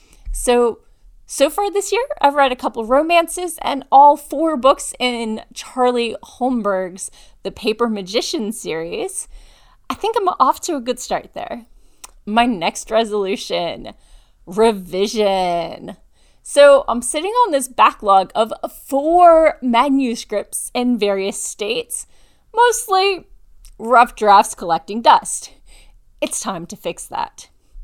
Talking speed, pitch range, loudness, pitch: 120 wpm, 215-315 Hz, -17 LUFS, 250 Hz